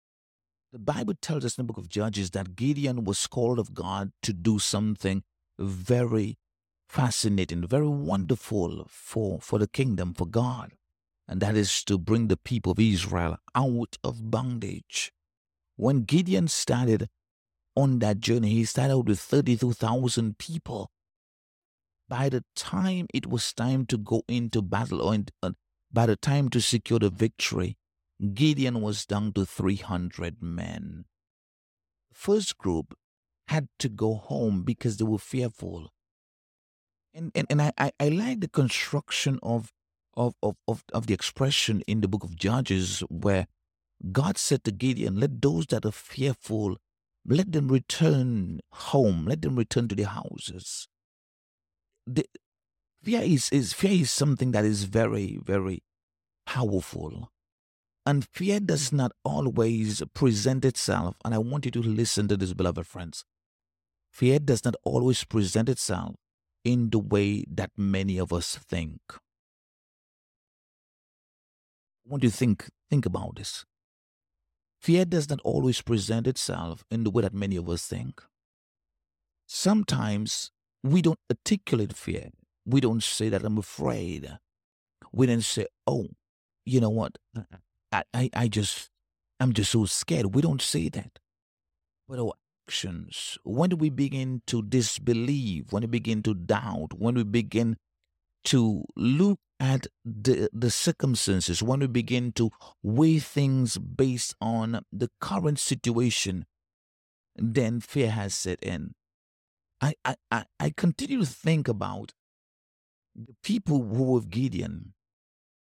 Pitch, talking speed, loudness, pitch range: 110 Hz, 140 wpm, -27 LUFS, 95-130 Hz